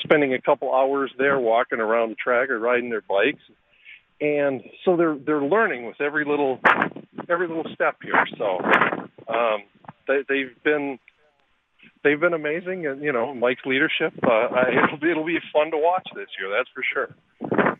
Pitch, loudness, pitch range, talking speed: 145 Hz, -22 LUFS, 130-170 Hz, 170 wpm